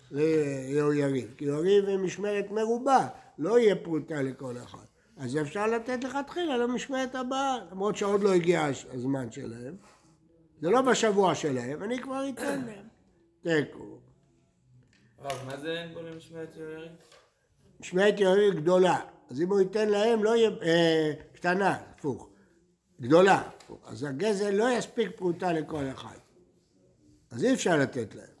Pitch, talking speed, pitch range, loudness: 175 Hz, 135 wpm, 150-215 Hz, -28 LUFS